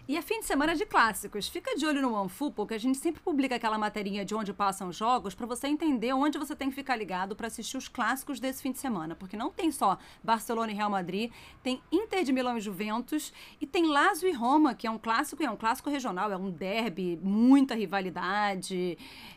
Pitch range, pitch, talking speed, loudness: 210-290 Hz, 245 Hz, 230 wpm, -30 LUFS